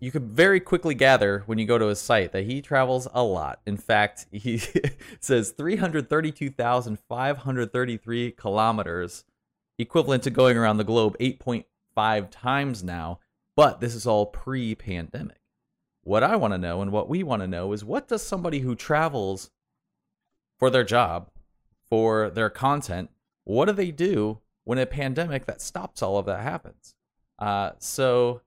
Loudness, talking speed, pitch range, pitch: -25 LUFS, 160 wpm, 105-135 Hz, 120 Hz